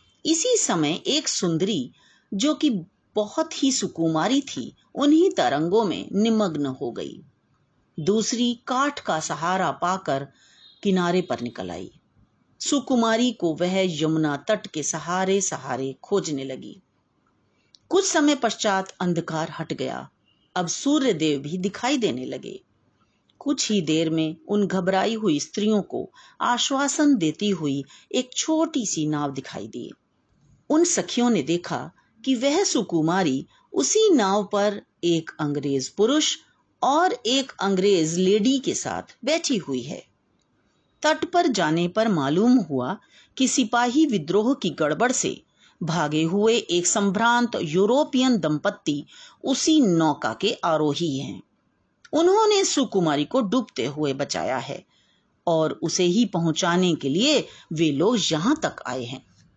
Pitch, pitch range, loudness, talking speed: 200 Hz, 160-265 Hz, -23 LUFS, 130 wpm